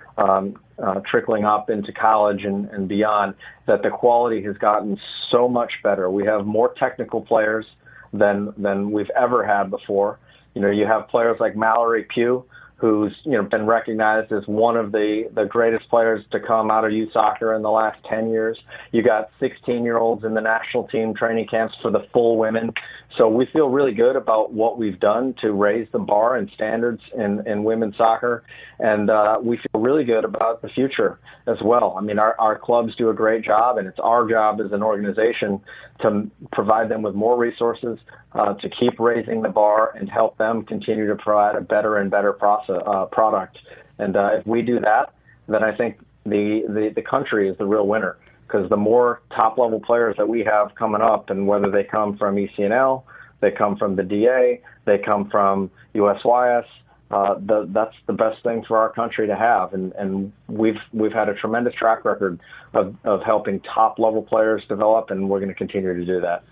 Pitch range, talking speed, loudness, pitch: 105-115 Hz, 200 wpm, -20 LUFS, 110 Hz